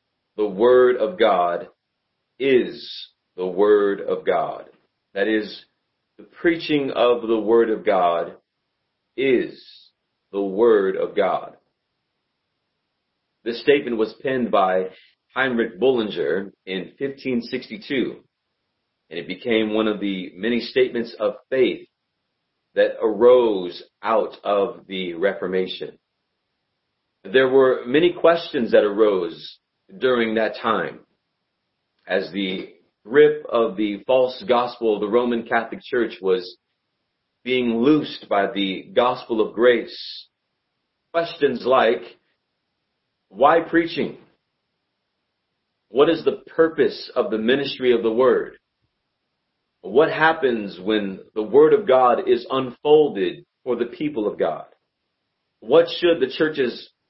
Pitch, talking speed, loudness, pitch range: 125 Hz, 115 wpm, -20 LUFS, 105-170 Hz